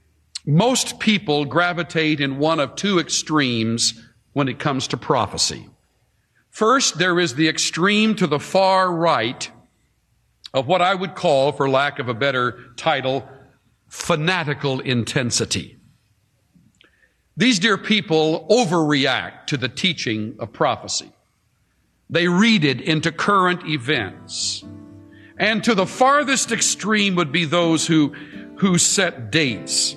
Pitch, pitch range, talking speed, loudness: 155 Hz, 130-180 Hz, 125 wpm, -19 LUFS